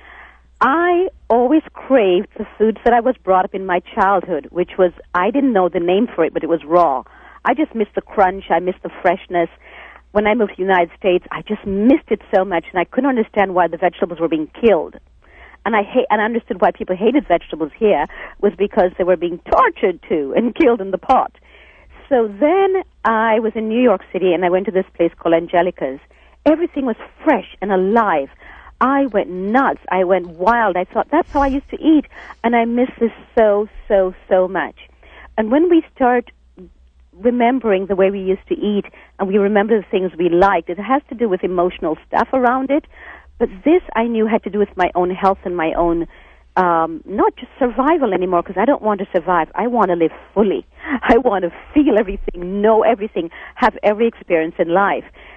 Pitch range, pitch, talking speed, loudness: 180-240 Hz, 200 Hz, 210 wpm, -17 LUFS